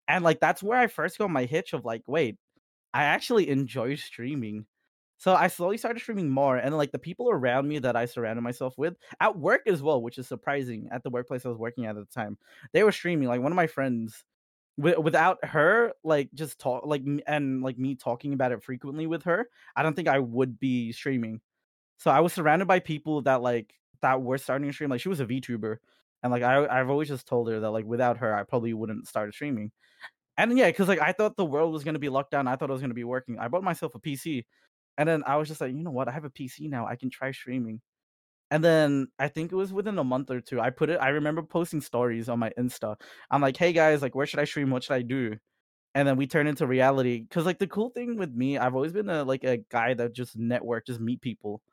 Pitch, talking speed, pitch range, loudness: 135 Hz, 255 wpm, 125-155 Hz, -27 LUFS